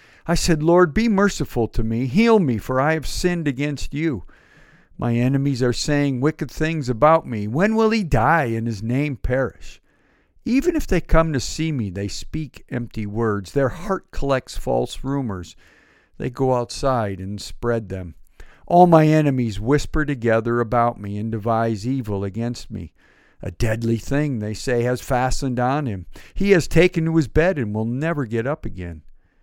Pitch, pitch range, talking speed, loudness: 130 Hz, 110-155 Hz, 175 wpm, -21 LUFS